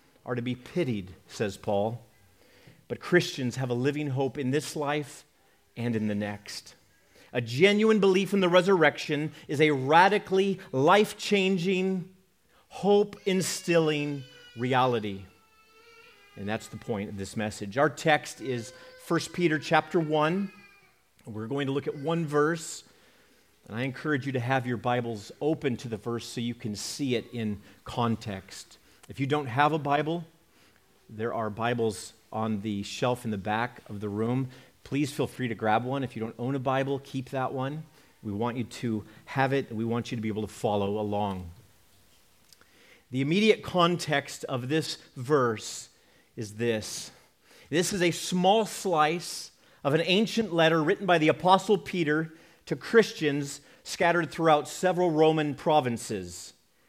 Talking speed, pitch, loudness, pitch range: 155 wpm, 135 Hz, -28 LUFS, 115-165 Hz